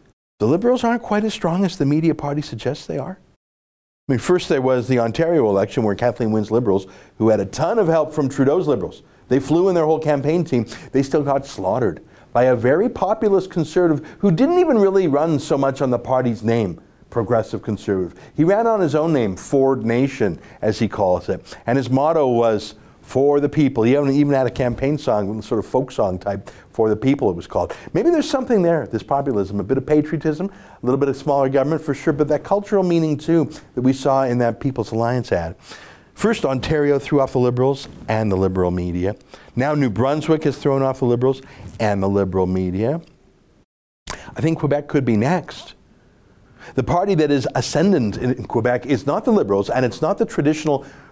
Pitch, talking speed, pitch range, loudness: 135 Hz, 205 wpm, 115-155 Hz, -19 LUFS